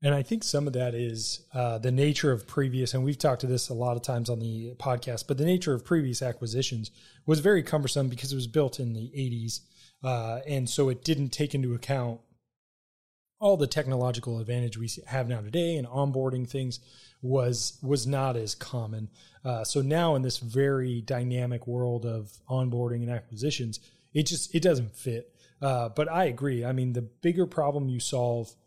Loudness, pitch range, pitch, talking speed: -29 LUFS, 120-140 Hz, 125 Hz, 195 wpm